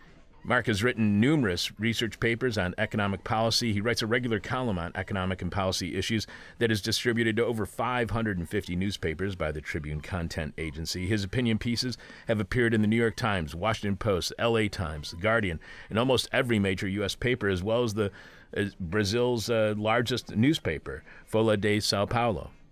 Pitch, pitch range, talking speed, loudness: 110 Hz, 95-115 Hz, 175 wpm, -28 LUFS